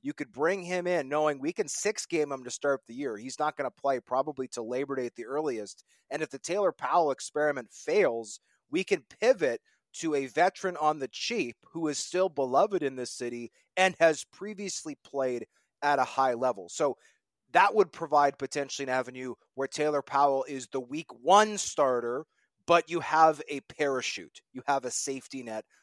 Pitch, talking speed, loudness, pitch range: 145 Hz, 195 wpm, -29 LUFS, 130-170 Hz